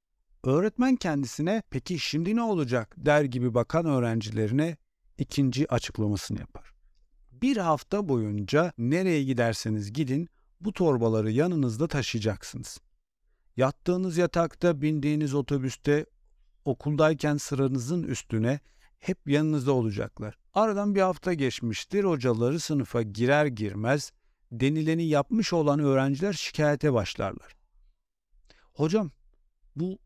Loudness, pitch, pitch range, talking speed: -27 LUFS, 145 Hz, 125-165 Hz, 100 wpm